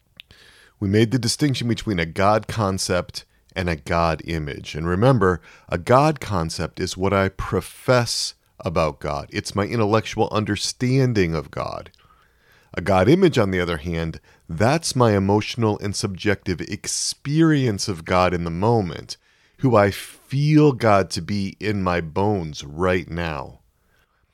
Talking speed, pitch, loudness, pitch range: 145 wpm, 100 Hz, -21 LUFS, 90-115 Hz